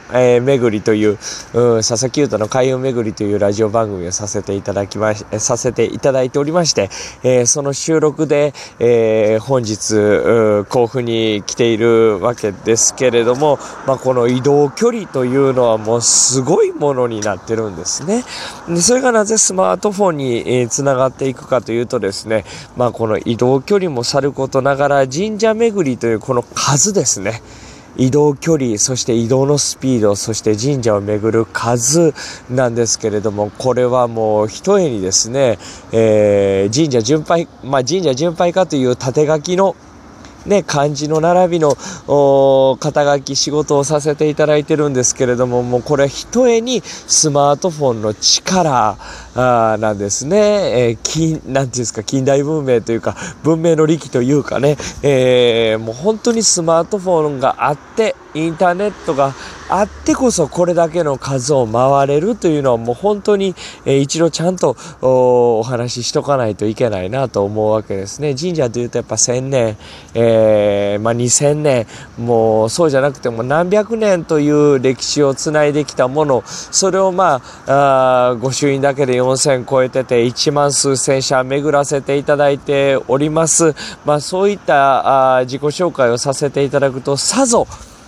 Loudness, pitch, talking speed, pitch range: -14 LUFS, 135 Hz, 330 characters per minute, 115-150 Hz